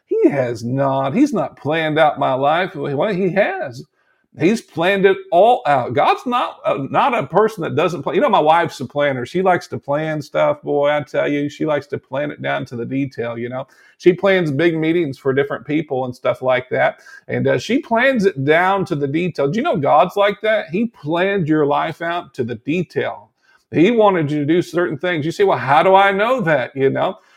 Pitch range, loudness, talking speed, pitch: 140-195 Hz, -17 LUFS, 225 wpm, 160 Hz